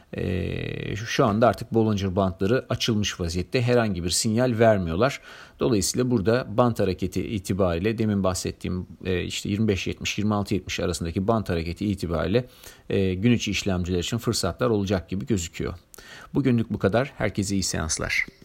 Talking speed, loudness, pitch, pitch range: 135 wpm, -25 LUFS, 100 Hz, 90-115 Hz